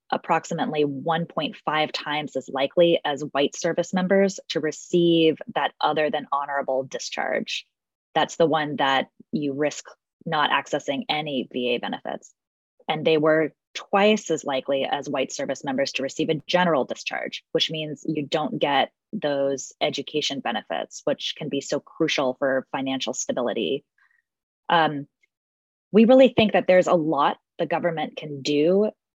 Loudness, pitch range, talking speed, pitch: -24 LUFS, 140-170 Hz, 145 wpm, 155 Hz